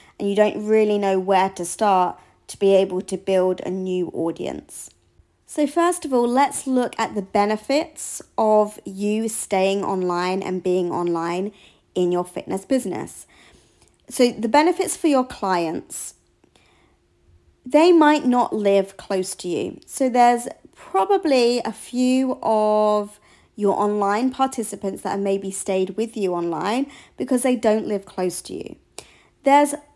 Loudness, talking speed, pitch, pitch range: -21 LUFS, 145 wpm, 210 Hz, 190-255 Hz